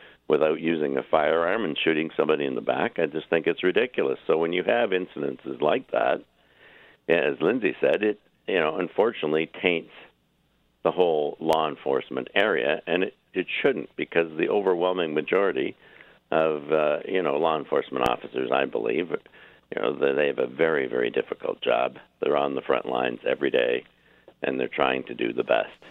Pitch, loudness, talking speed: 370 Hz, -25 LUFS, 175 wpm